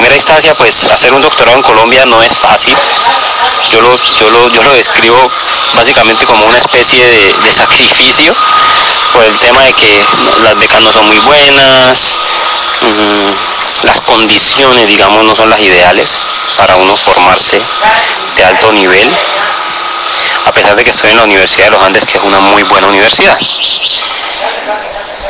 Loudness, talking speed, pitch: -3 LUFS, 155 wpm, 130 Hz